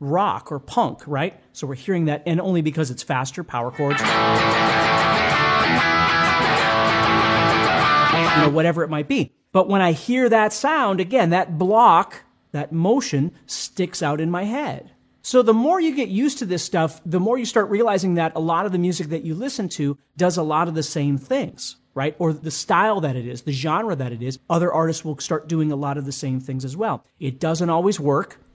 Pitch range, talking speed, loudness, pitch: 140-190 Hz, 205 wpm, -20 LUFS, 160 Hz